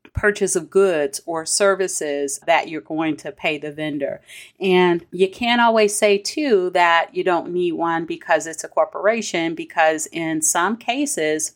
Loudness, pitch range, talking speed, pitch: -19 LUFS, 160-195 Hz, 160 wpm, 170 Hz